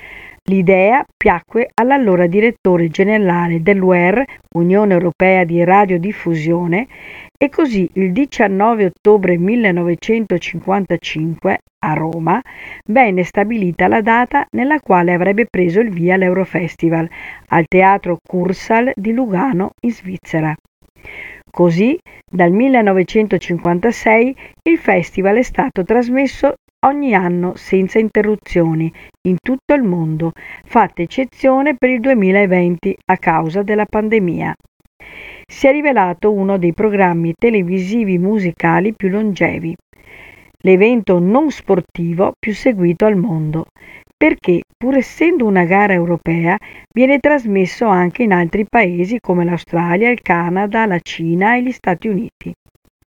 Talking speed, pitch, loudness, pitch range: 115 wpm, 195 Hz, -14 LUFS, 175-225 Hz